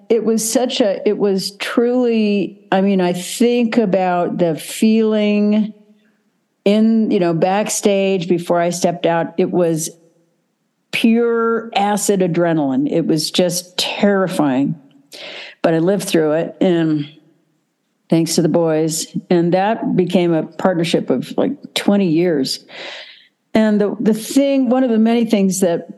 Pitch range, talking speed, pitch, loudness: 175-225 Hz, 140 wpm, 200 Hz, -16 LUFS